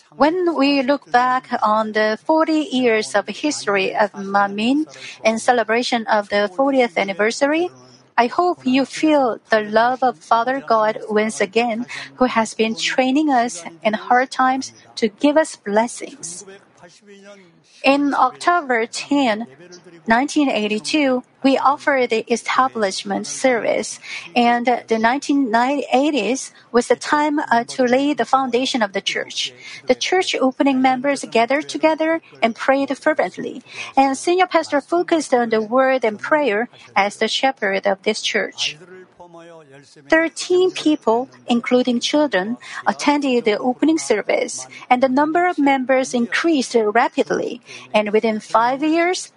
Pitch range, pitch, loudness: 220-280 Hz, 250 Hz, -18 LUFS